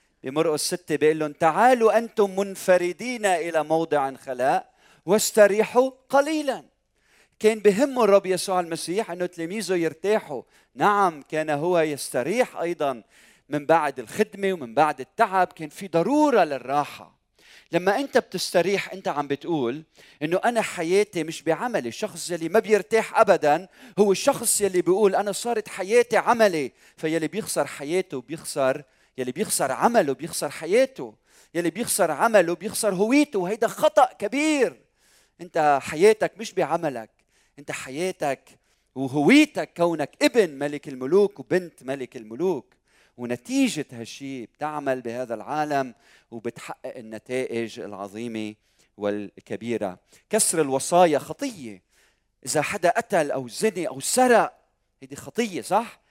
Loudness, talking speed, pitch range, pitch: -23 LUFS, 120 wpm, 140-210 Hz, 170 Hz